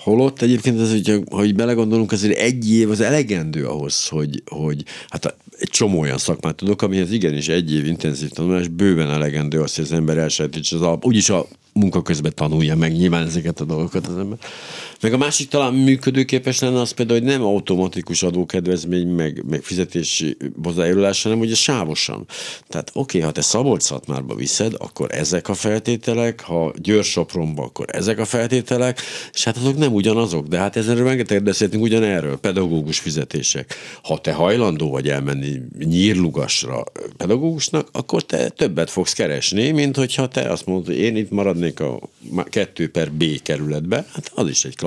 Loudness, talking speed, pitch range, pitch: -19 LUFS, 170 wpm, 80-115 Hz, 100 Hz